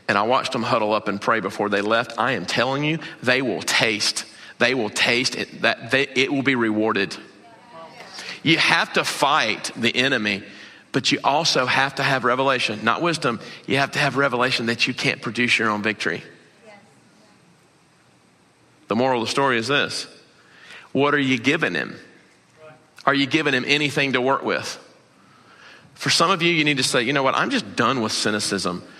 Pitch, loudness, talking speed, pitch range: 130 Hz, -20 LUFS, 190 wpm, 115-140 Hz